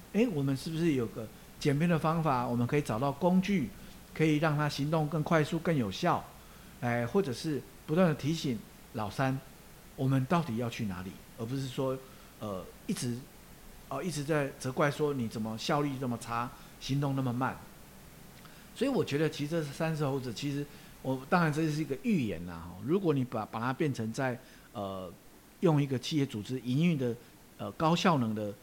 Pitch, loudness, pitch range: 140 Hz, -32 LUFS, 120-160 Hz